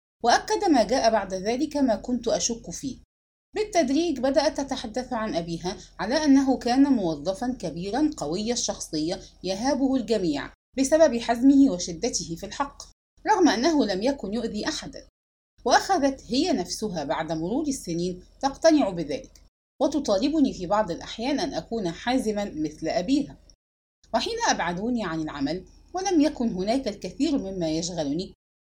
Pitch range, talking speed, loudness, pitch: 190-290 Hz, 130 wpm, -25 LUFS, 245 Hz